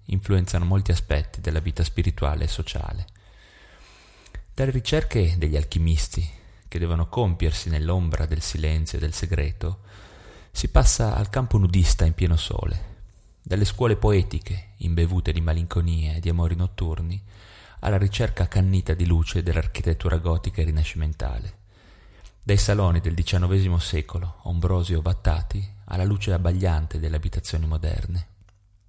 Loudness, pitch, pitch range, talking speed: -24 LUFS, 90 Hz, 85-100 Hz, 130 wpm